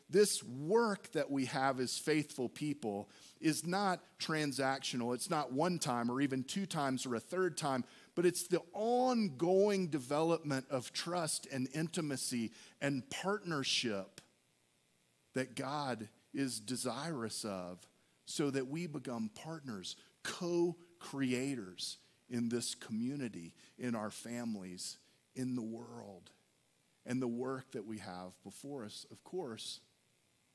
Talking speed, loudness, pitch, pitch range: 130 wpm, -38 LUFS, 135 Hz, 120-170 Hz